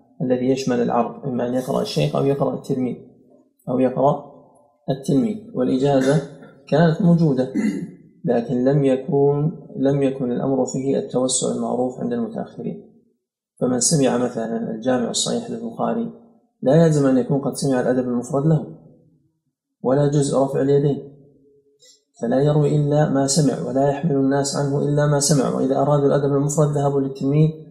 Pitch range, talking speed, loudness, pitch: 135-150 Hz, 140 wpm, -20 LUFS, 140 Hz